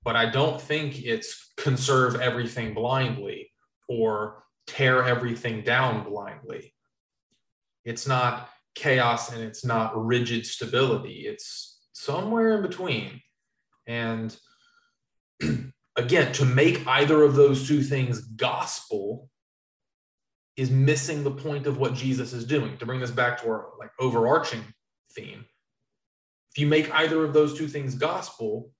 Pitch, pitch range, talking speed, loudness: 130 Hz, 115-150 Hz, 130 wpm, -25 LUFS